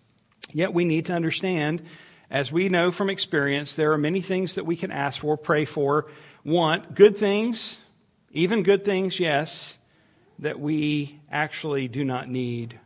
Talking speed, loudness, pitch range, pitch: 160 wpm, -24 LUFS, 145-185 Hz, 160 Hz